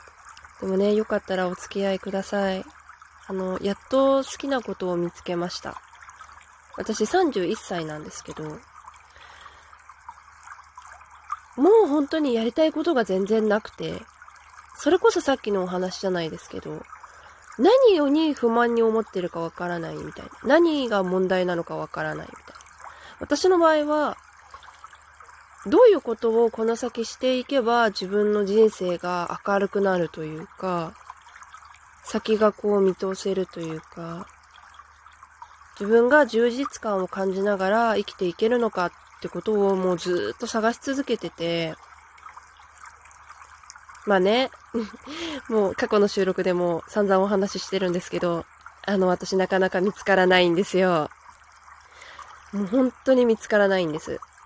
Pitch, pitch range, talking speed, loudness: 205 Hz, 185-240 Hz, 280 characters per minute, -23 LUFS